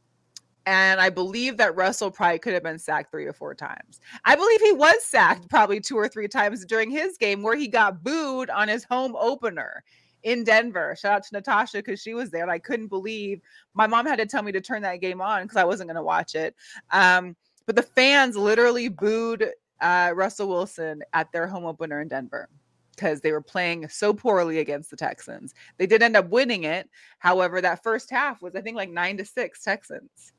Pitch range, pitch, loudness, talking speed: 180-235 Hz, 205 Hz, -23 LUFS, 215 wpm